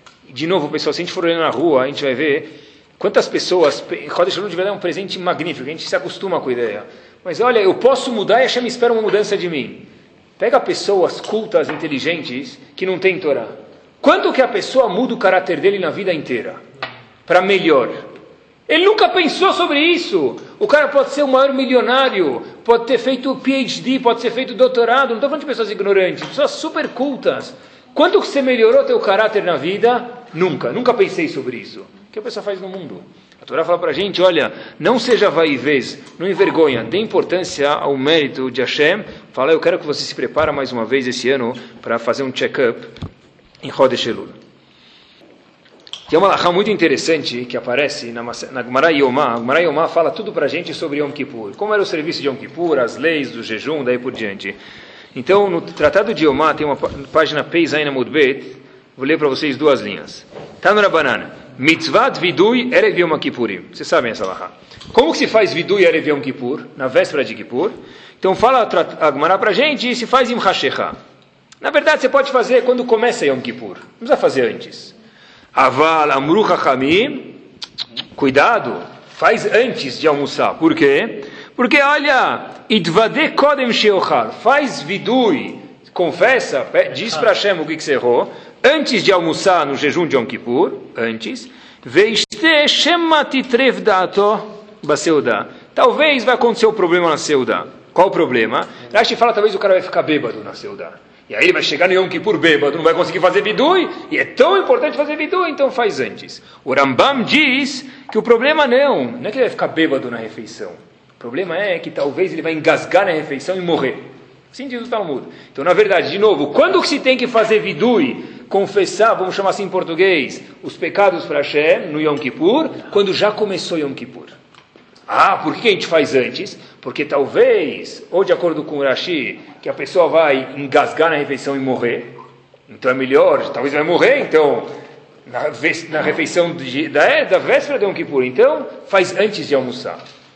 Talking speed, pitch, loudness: 185 wpm, 215 Hz, -15 LUFS